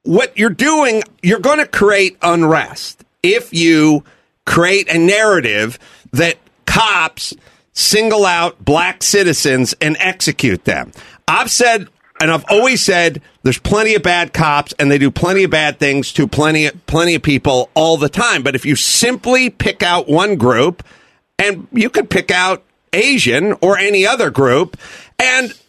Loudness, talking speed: -13 LUFS, 155 wpm